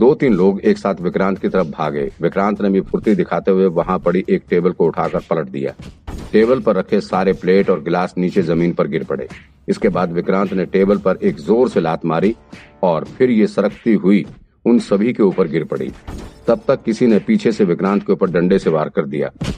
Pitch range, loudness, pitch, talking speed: 90-95 Hz, -17 LUFS, 95 Hz, 220 wpm